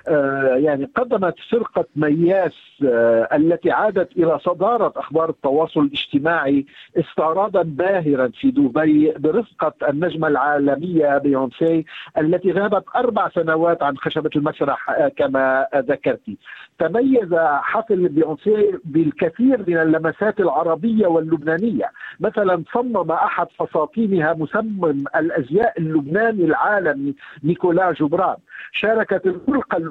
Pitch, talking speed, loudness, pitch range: 165 Hz, 100 wpm, -19 LUFS, 150-200 Hz